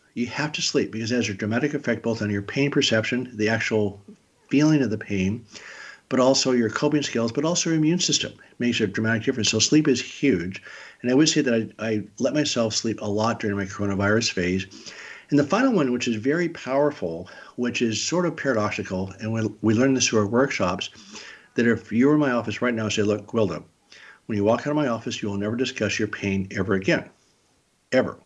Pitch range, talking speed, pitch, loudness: 105-135 Hz, 225 wpm, 115 Hz, -23 LUFS